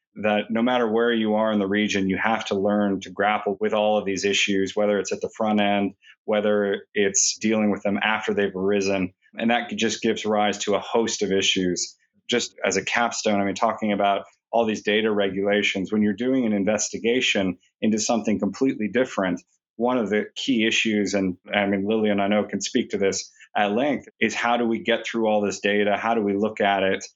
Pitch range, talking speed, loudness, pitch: 100-110 Hz, 215 wpm, -23 LUFS, 105 Hz